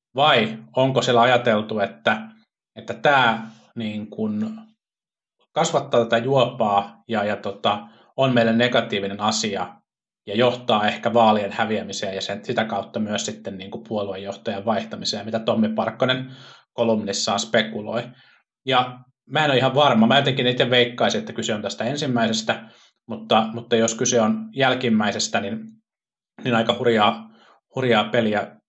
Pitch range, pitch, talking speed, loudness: 110-125 Hz, 115 Hz, 135 wpm, -21 LUFS